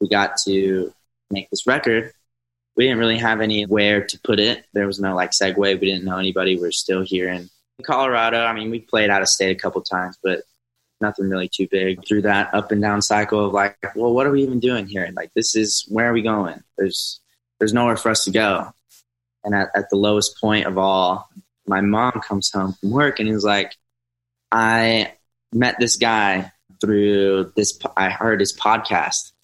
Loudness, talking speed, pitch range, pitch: -19 LUFS, 205 wpm, 95-115 Hz, 105 Hz